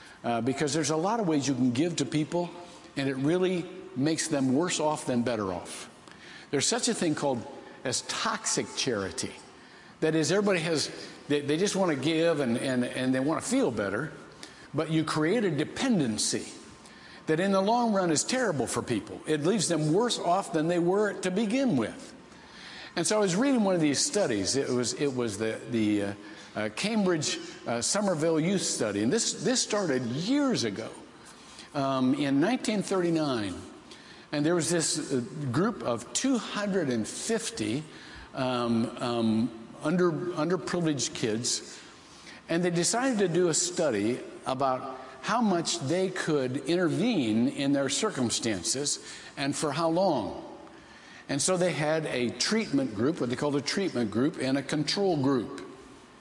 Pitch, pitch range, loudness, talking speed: 160 Hz, 135-195 Hz, -28 LUFS, 165 wpm